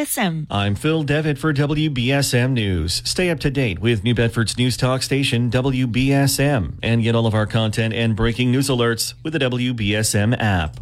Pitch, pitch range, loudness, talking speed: 125 Hz, 115-140 Hz, -19 LUFS, 170 wpm